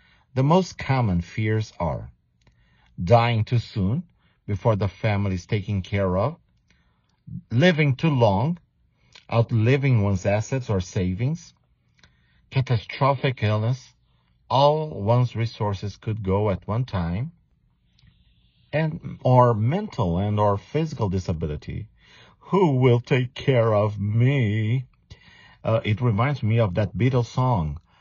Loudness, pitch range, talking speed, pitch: -23 LUFS, 100-130 Hz, 115 wpm, 115 Hz